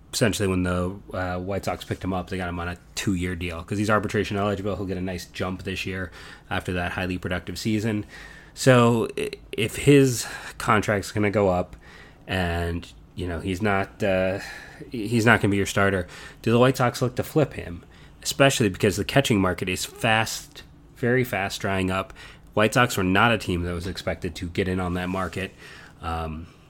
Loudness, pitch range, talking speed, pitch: -24 LUFS, 90-110 Hz, 200 wpm, 95 Hz